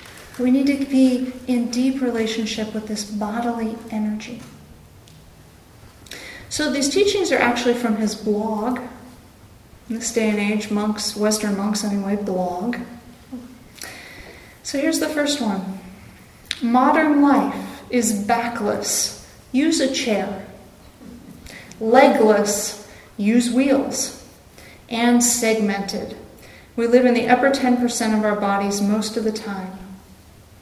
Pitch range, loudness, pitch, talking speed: 210-250 Hz, -20 LUFS, 225 Hz, 115 wpm